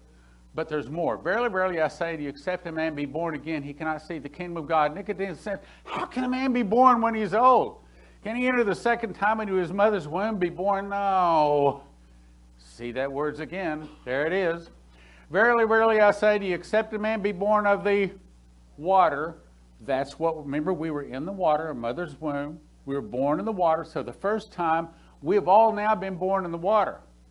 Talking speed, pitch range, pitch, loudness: 215 wpm, 145-210 Hz, 170 Hz, -25 LUFS